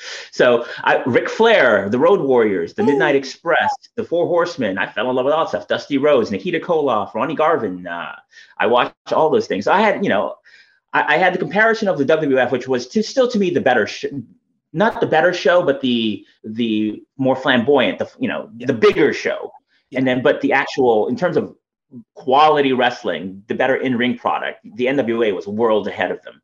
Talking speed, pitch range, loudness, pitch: 210 wpm, 125-190 Hz, -17 LUFS, 140 Hz